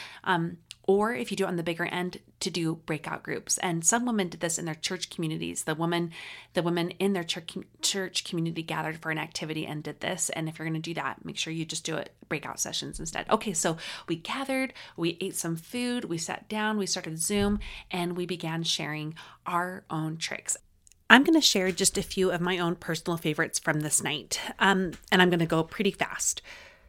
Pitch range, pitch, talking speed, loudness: 165-195 Hz, 175 Hz, 215 wpm, -28 LUFS